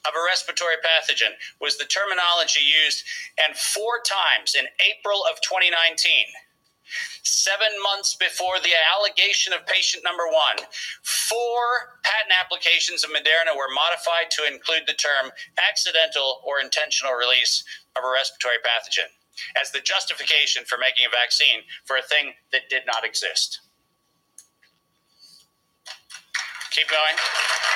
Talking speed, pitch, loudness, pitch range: 130 wpm, 170 Hz, -20 LUFS, 155-205 Hz